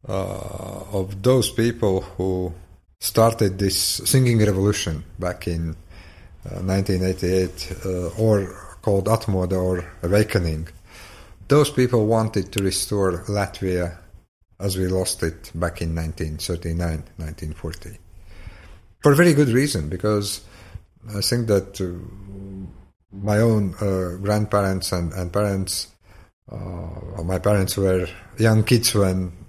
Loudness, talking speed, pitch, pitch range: -22 LUFS, 115 wpm, 95 Hz, 90-105 Hz